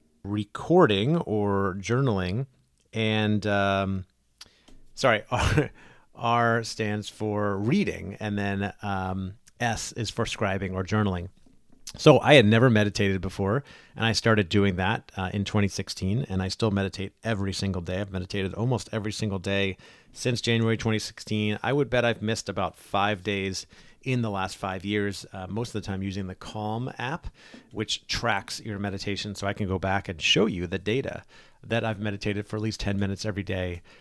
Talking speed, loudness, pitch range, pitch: 170 wpm, -26 LUFS, 95-110 Hz, 105 Hz